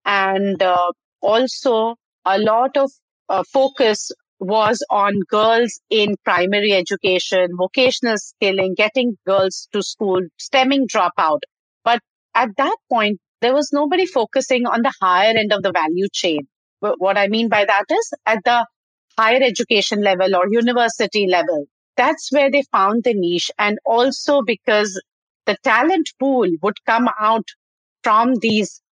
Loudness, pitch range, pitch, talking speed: -17 LUFS, 195-250 Hz, 220 Hz, 145 wpm